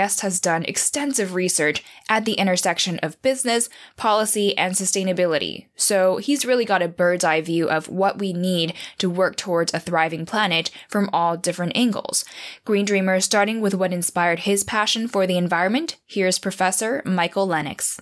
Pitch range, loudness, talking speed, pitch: 175-205 Hz, -21 LUFS, 165 wpm, 185 Hz